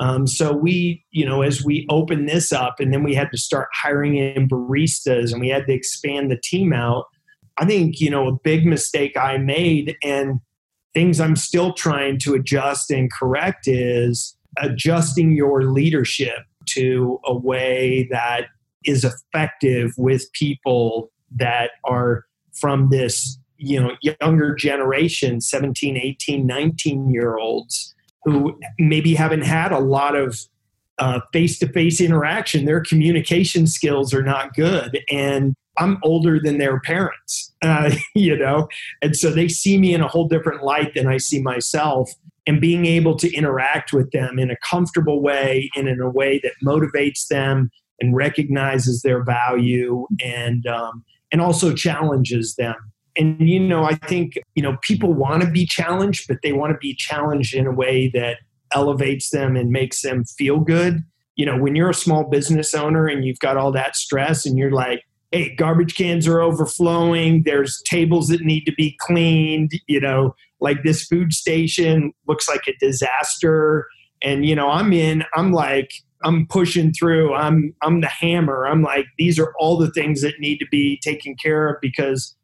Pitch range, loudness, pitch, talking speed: 130-160 Hz, -19 LUFS, 145 Hz, 170 wpm